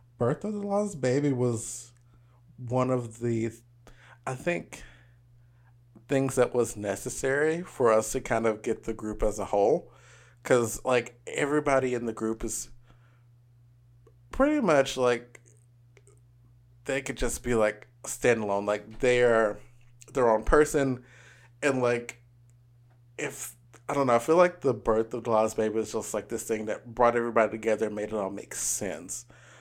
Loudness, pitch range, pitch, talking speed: -28 LUFS, 115-130 Hz, 120 Hz, 155 wpm